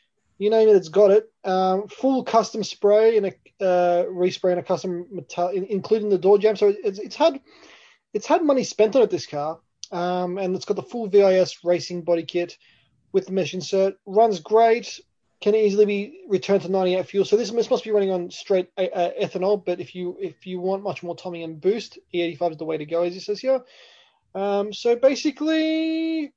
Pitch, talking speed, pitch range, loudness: 195 Hz, 210 wpm, 180-220 Hz, -22 LUFS